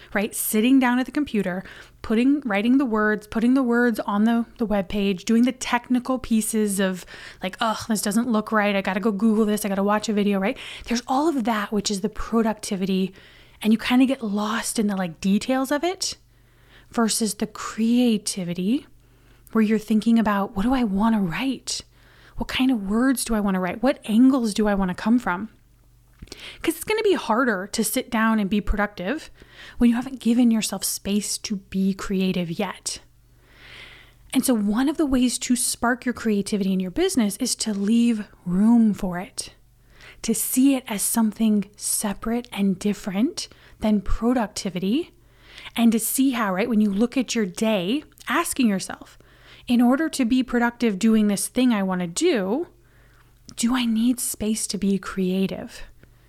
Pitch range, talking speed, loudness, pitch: 205-245 Hz, 185 wpm, -22 LUFS, 220 Hz